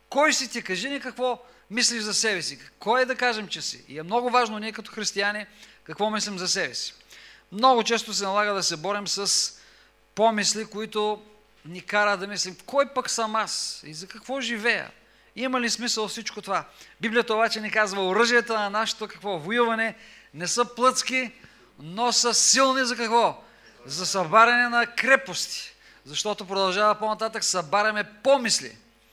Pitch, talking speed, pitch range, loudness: 220 Hz, 165 wpm, 200-240 Hz, -24 LUFS